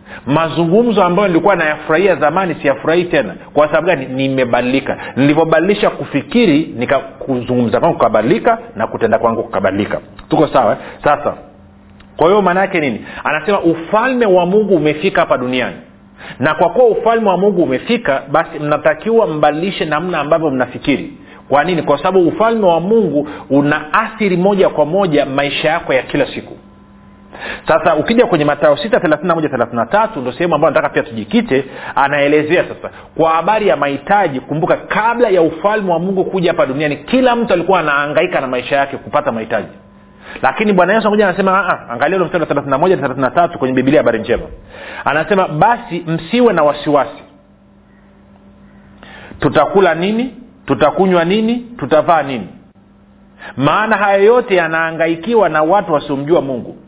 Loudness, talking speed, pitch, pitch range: -14 LUFS, 135 wpm, 165 Hz, 145-200 Hz